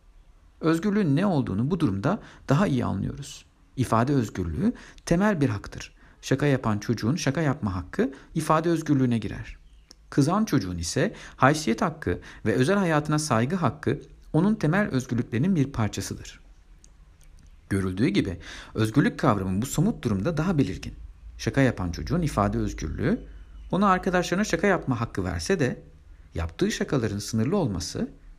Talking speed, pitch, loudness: 130 wpm, 120 Hz, -26 LUFS